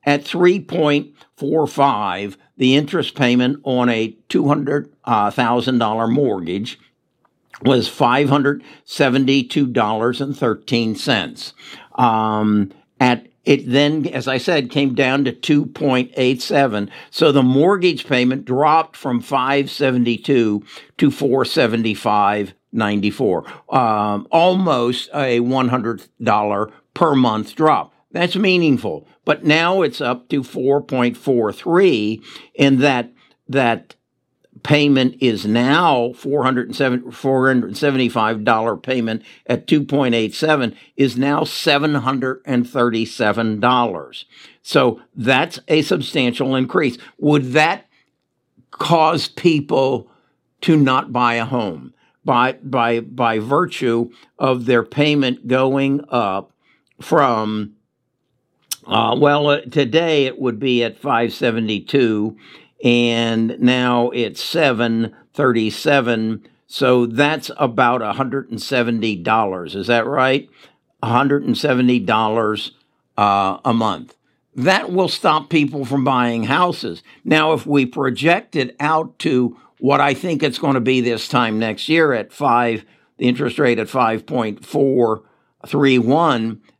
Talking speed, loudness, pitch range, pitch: 105 wpm, -17 LUFS, 115-140 Hz, 130 Hz